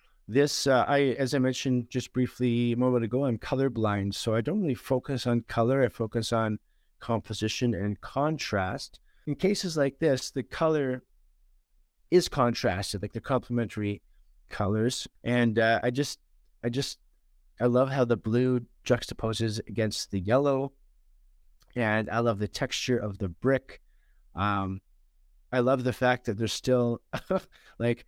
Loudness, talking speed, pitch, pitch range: -28 LUFS, 150 wpm, 120 Hz, 105-130 Hz